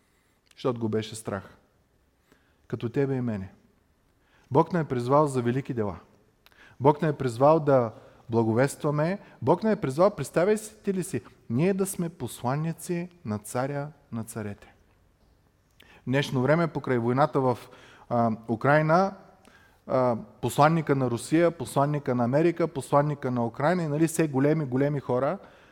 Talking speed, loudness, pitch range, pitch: 145 wpm, -26 LUFS, 120-155 Hz, 135 Hz